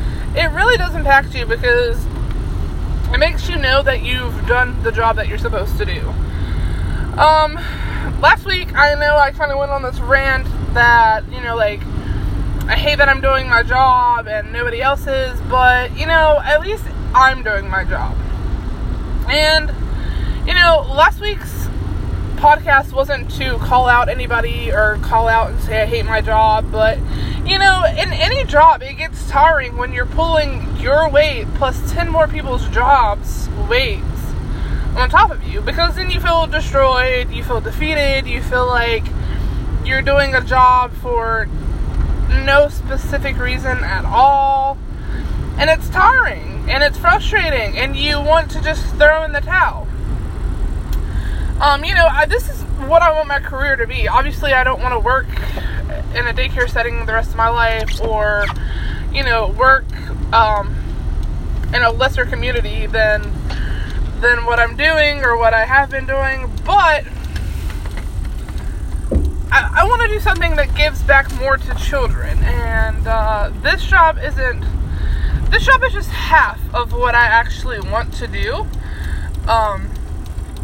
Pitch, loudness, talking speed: 250 Hz, -15 LUFS, 160 wpm